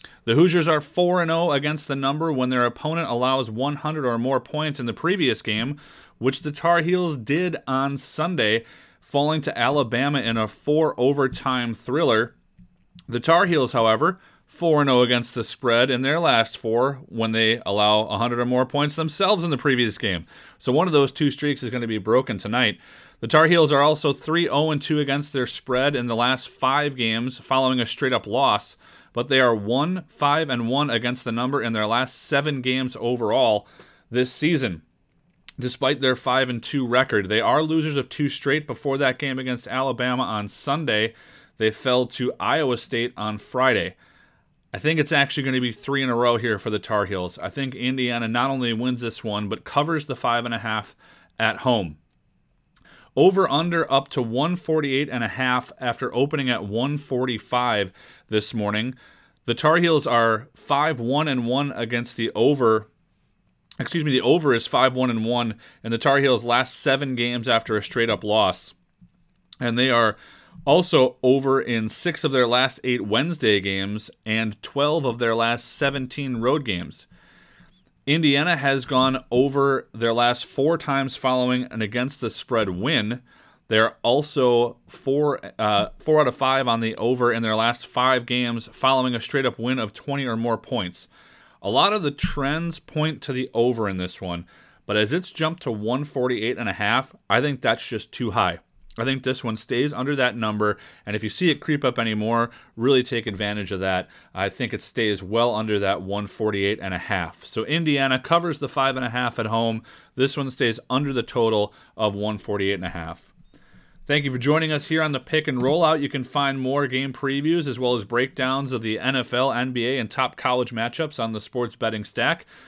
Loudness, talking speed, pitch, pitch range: -22 LUFS, 185 wpm, 125 Hz, 115-140 Hz